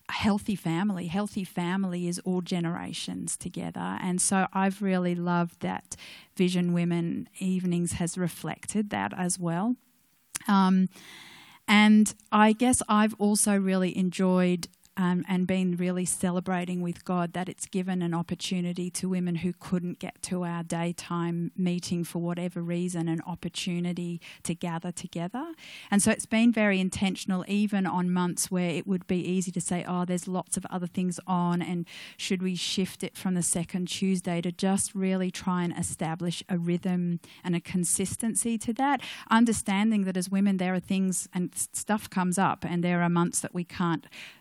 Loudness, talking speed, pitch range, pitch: -28 LUFS, 165 wpm, 175-195 Hz, 180 Hz